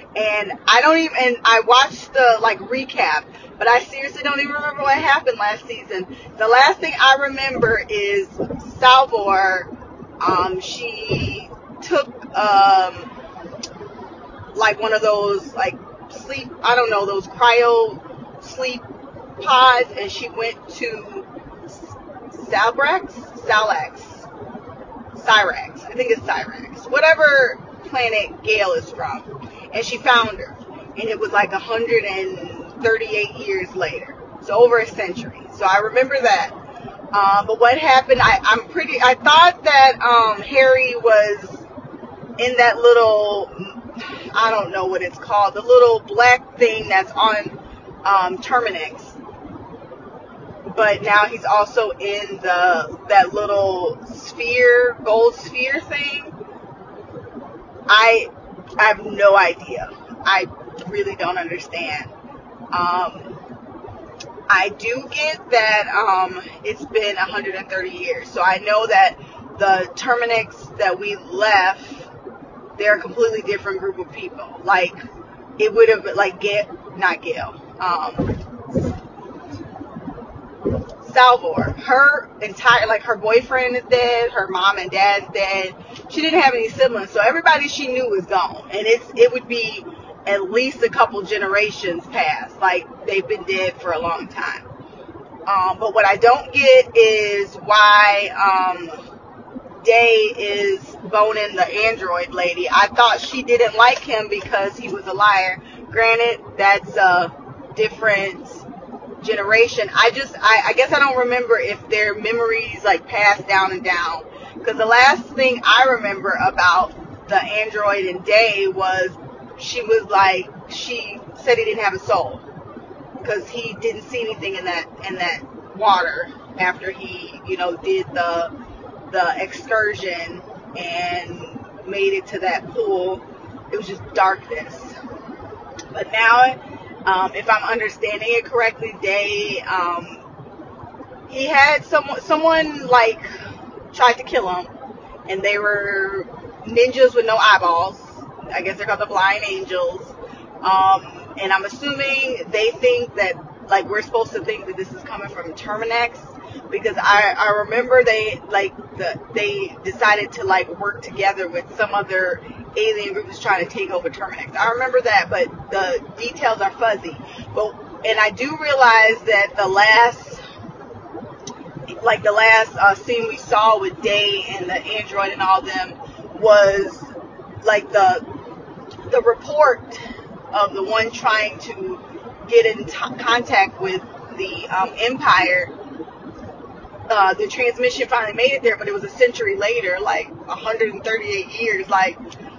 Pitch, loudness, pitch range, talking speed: 230 Hz, -17 LUFS, 200-295 Hz, 140 wpm